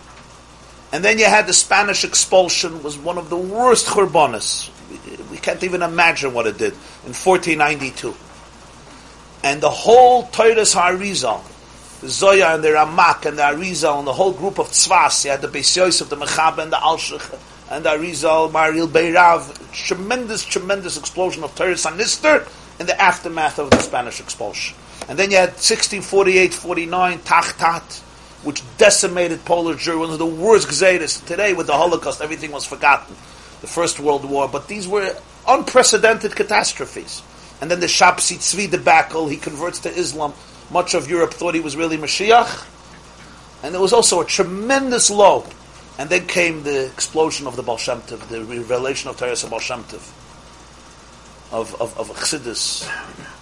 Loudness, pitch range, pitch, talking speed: -16 LUFS, 150-195 Hz, 175 Hz, 160 wpm